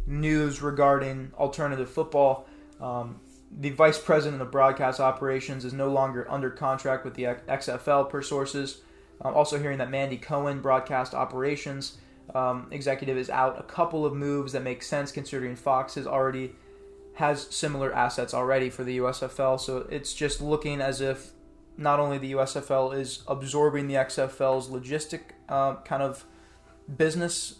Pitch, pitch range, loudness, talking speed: 135 Hz, 130-145 Hz, -28 LUFS, 150 wpm